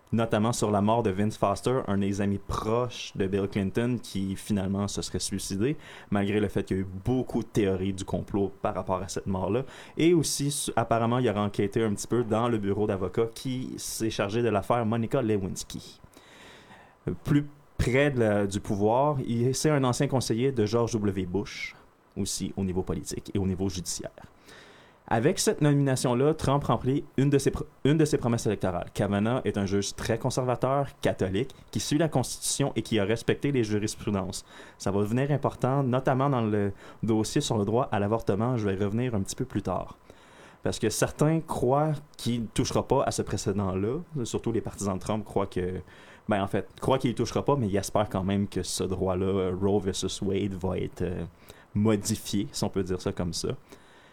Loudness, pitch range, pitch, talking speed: -28 LUFS, 100-125 Hz, 110 Hz, 195 wpm